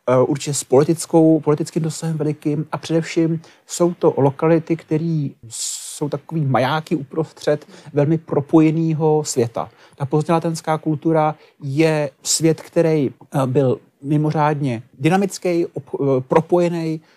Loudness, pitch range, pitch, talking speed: -19 LUFS, 145-165 Hz, 155 Hz, 100 wpm